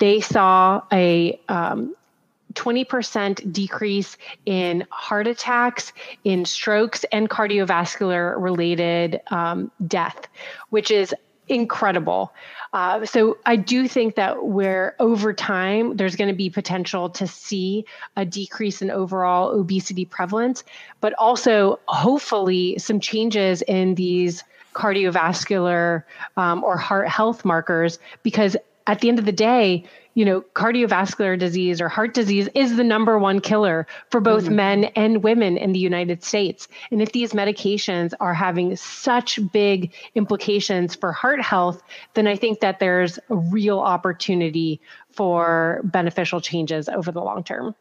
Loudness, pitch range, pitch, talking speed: -21 LUFS, 180-220 Hz, 200 Hz, 135 wpm